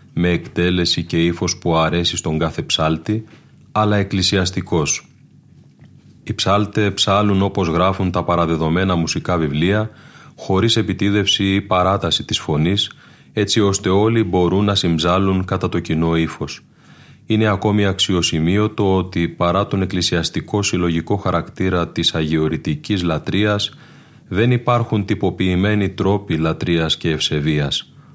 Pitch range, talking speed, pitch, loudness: 85-105 Hz, 120 wpm, 95 Hz, -18 LUFS